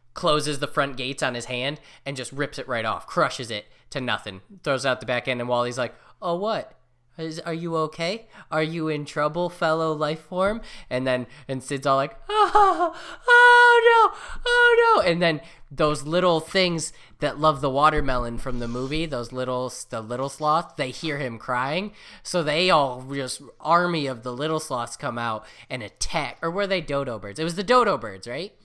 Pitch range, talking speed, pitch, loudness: 130-175 Hz, 200 wpm, 150 Hz, -23 LUFS